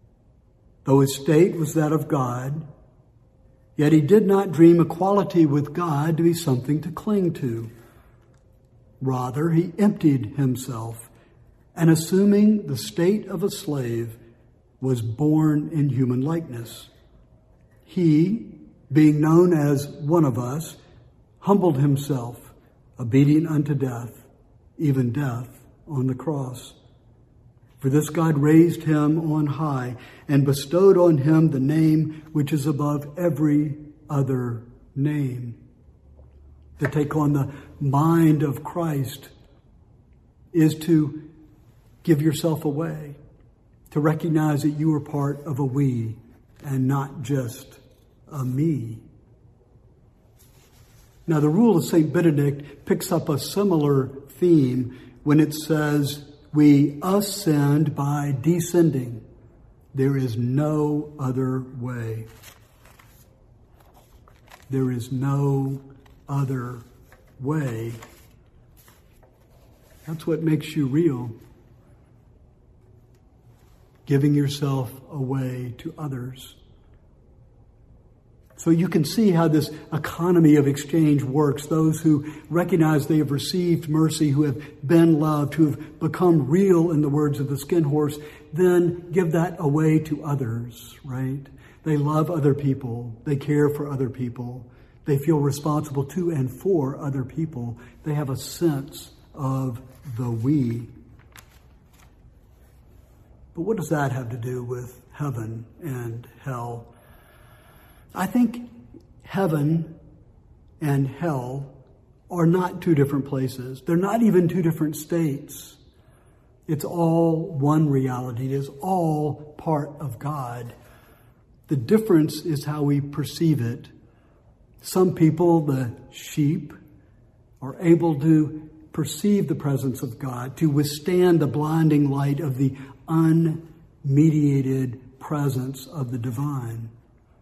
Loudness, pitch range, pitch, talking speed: -22 LUFS, 125-155 Hz, 145 Hz, 115 wpm